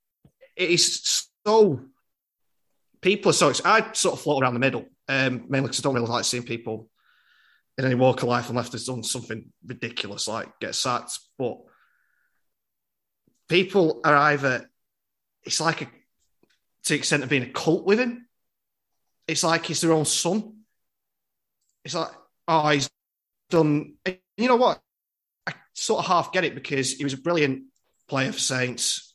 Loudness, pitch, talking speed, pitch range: -23 LUFS, 140 Hz, 165 wpm, 125-170 Hz